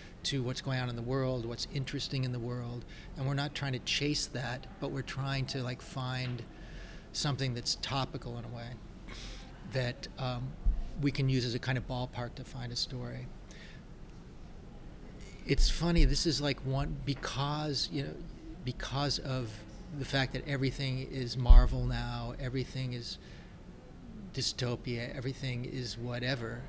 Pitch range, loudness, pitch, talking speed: 120-135 Hz, -35 LUFS, 130 Hz, 155 wpm